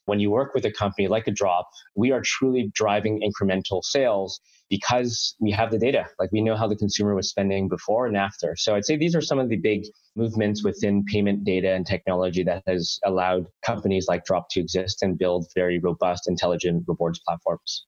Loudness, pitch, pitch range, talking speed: -24 LUFS, 100 Hz, 90-105 Hz, 205 wpm